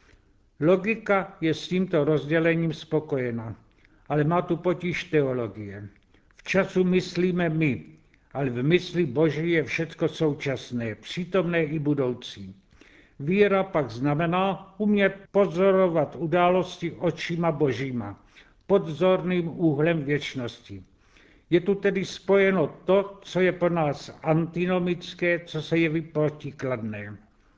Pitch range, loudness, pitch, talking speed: 130-180 Hz, -25 LUFS, 160 Hz, 110 wpm